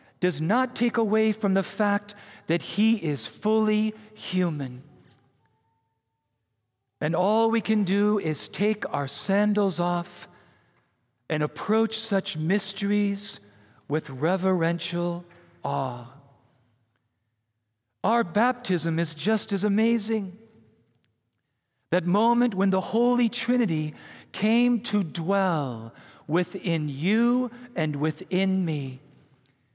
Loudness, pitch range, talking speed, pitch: -25 LUFS, 135-210 Hz, 100 wpm, 175 Hz